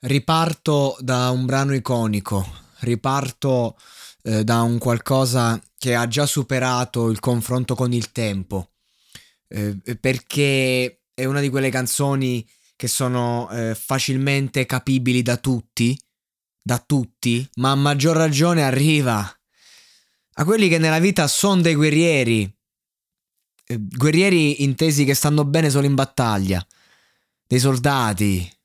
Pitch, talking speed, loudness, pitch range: 130 Hz, 125 wpm, -20 LUFS, 115-140 Hz